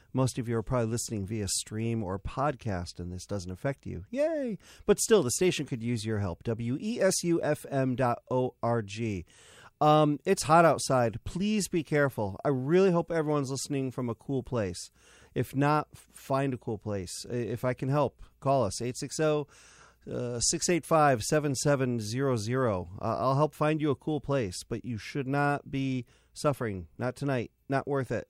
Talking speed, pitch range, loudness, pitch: 175 wpm, 115-150 Hz, -29 LUFS, 130 Hz